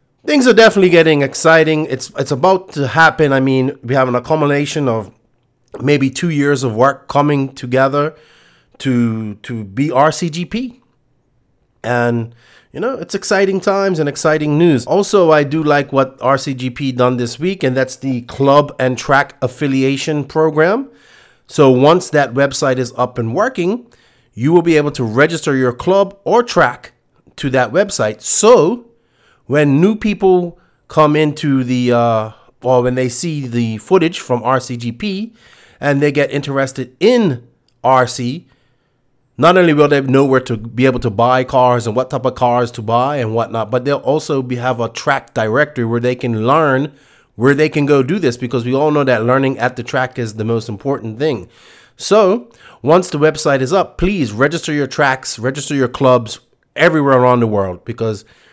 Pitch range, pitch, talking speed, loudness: 125-155 Hz, 135 Hz, 175 wpm, -14 LUFS